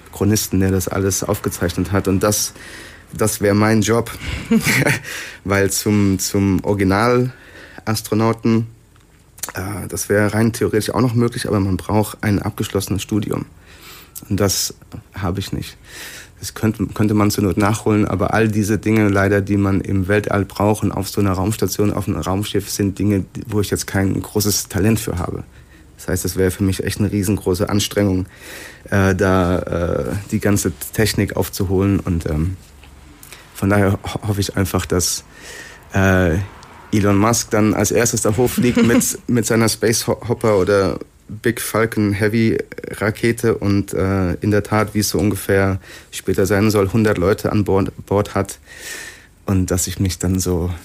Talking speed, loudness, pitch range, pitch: 160 wpm, -18 LUFS, 95-105 Hz, 100 Hz